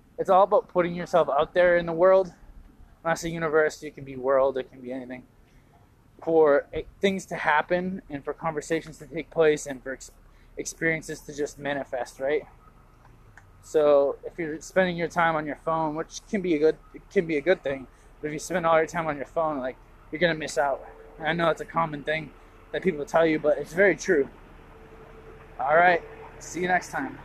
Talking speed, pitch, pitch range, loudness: 210 wpm, 155 Hz, 140-165 Hz, -25 LUFS